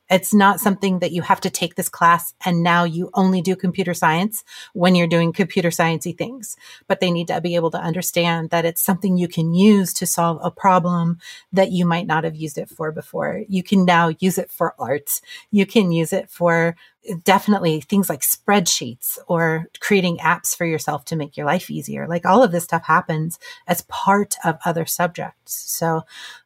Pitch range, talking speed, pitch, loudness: 170-195 Hz, 200 wpm, 175 Hz, -19 LUFS